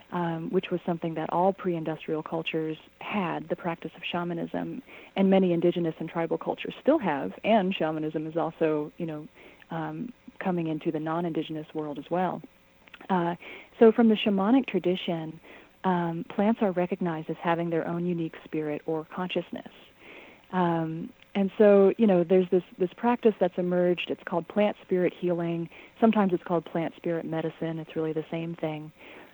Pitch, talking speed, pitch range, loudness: 170 Hz, 165 wpm, 160-185 Hz, -28 LUFS